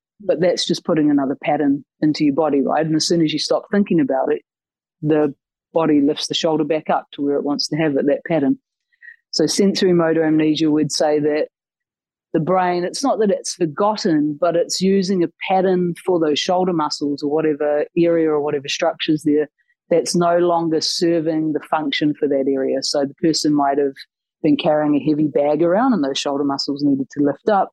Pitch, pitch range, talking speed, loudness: 155 Hz, 150-175 Hz, 200 wpm, -18 LUFS